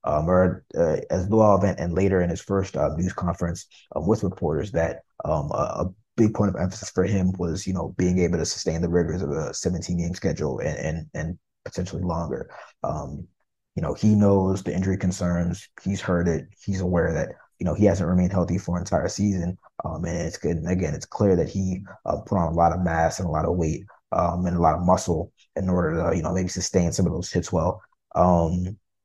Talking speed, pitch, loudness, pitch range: 235 wpm, 90 Hz, -24 LUFS, 85-95 Hz